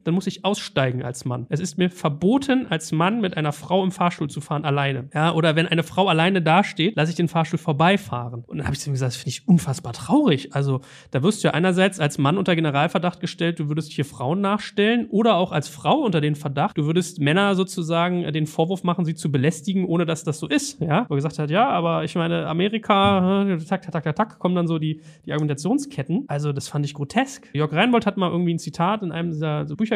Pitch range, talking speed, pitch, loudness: 150-190 Hz, 240 wpm, 165 Hz, -22 LUFS